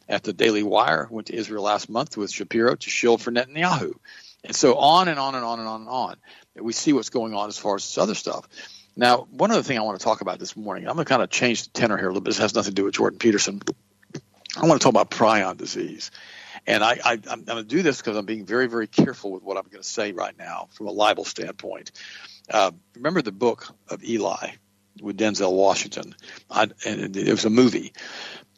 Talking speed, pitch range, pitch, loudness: 245 wpm, 105-125 Hz, 110 Hz, -23 LUFS